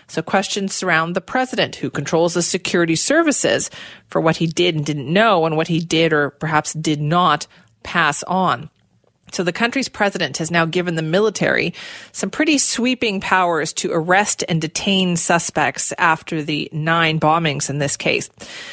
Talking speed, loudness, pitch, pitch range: 165 wpm, -17 LUFS, 170 Hz, 160-195 Hz